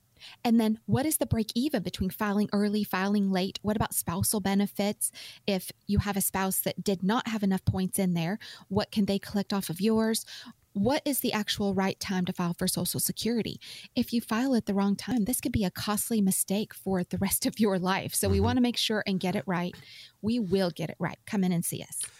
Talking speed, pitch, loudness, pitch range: 230 wpm, 200 Hz, -29 LUFS, 185-220 Hz